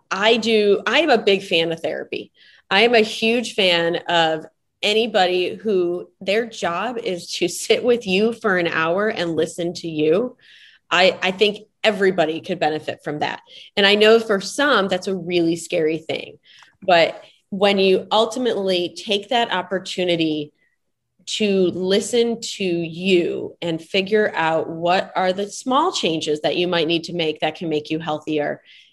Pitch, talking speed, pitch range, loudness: 185 Hz, 165 wpm, 165-215 Hz, -19 LUFS